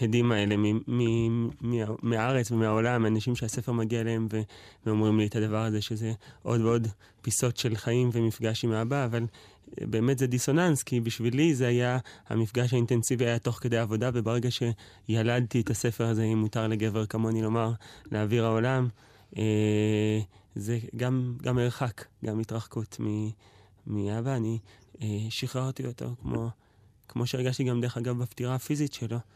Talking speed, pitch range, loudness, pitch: 150 wpm, 110-125 Hz, -29 LUFS, 115 Hz